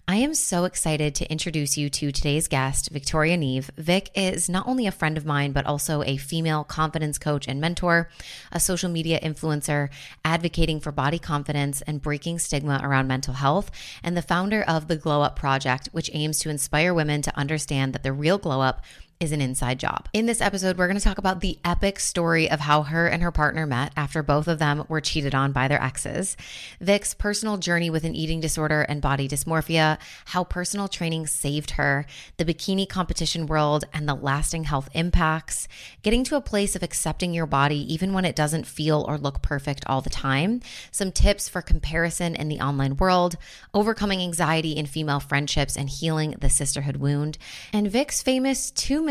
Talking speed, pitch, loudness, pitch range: 195 wpm, 155 Hz, -24 LUFS, 145-175 Hz